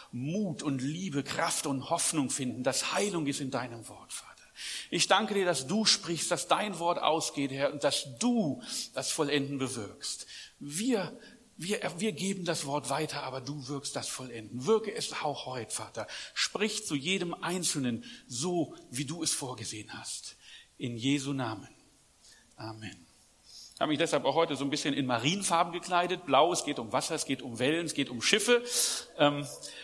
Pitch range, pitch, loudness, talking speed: 135-180 Hz, 150 Hz, -31 LUFS, 175 wpm